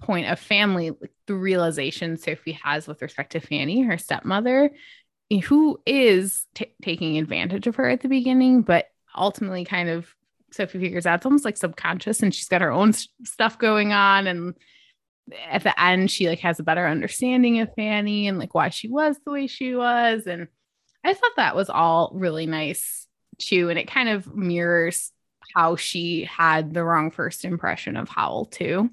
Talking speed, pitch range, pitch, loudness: 185 wpm, 170-230 Hz, 190 Hz, -22 LUFS